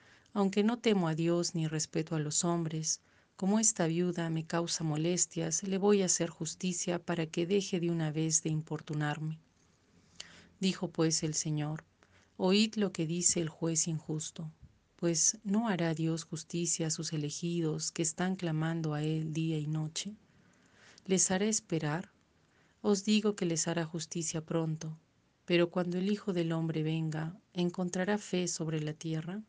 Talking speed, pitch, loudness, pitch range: 160 wpm, 165 Hz, -33 LUFS, 160-185 Hz